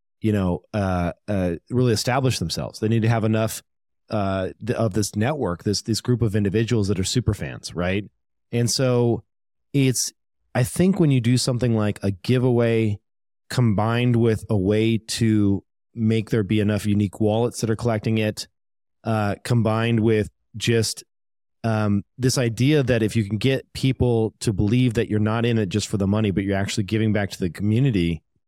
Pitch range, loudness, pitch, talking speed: 105-120 Hz, -22 LUFS, 110 Hz, 180 wpm